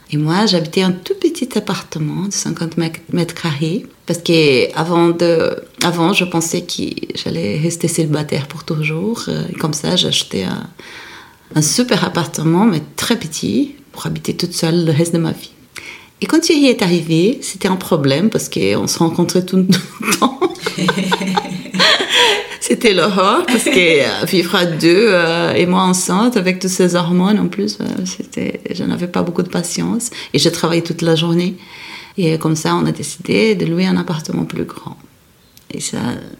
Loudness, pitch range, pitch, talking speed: -15 LUFS, 165-215 Hz, 180 Hz, 170 wpm